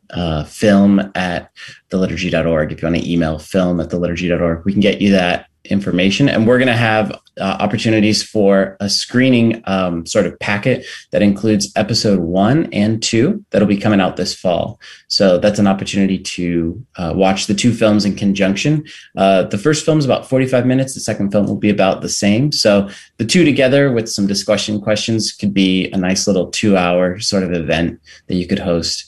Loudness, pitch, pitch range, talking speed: -15 LUFS, 100 Hz, 90-110 Hz, 200 wpm